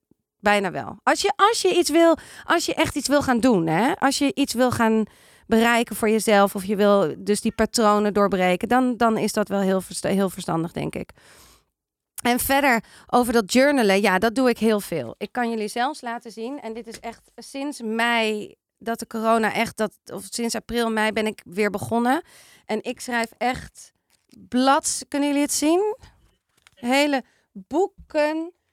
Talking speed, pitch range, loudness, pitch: 185 wpm, 210-270 Hz, -22 LUFS, 230 Hz